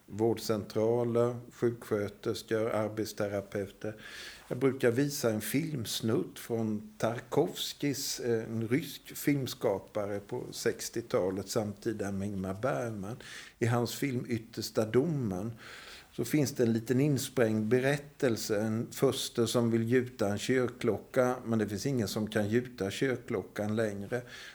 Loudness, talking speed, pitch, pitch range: -32 LUFS, 115 wpm, 115 Hz, 110-125 Hz